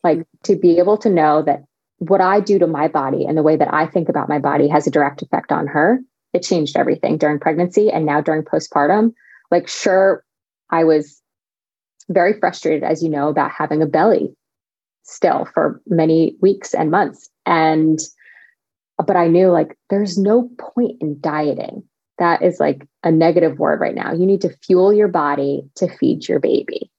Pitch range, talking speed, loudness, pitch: 155-195 Hz, 185 wpm, -17 LUFS, 170 Hz